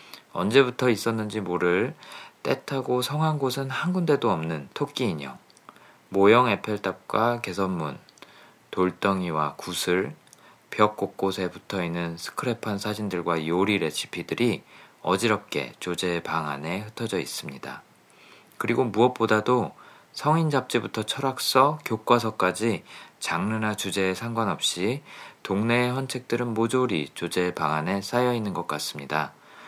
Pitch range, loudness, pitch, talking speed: 95-125 Hz, -26 LUFS, 110 Hz, 280 characters per minute